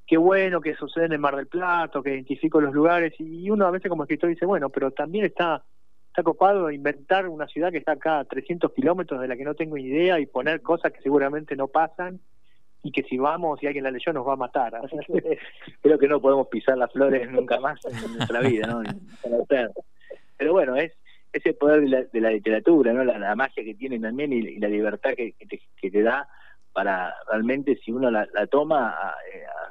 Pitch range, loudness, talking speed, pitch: 130-170 Hz, -24 LUFS, 225 wpm, 145 Hz